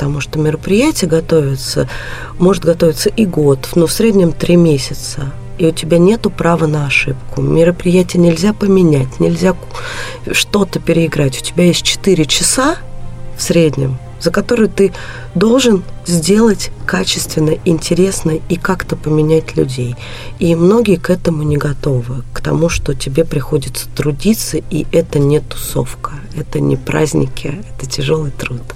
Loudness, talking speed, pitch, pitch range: -13 LUFS, 140 wpm, 160 Hz, 135-180 Hz